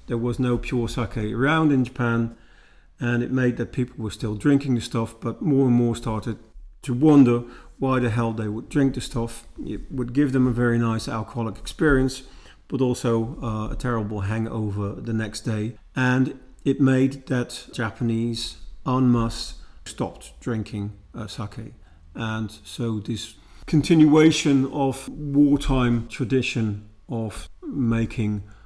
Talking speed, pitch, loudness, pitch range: 150 wpm, 120 Hz, -23 LUFS, 110-130 Hz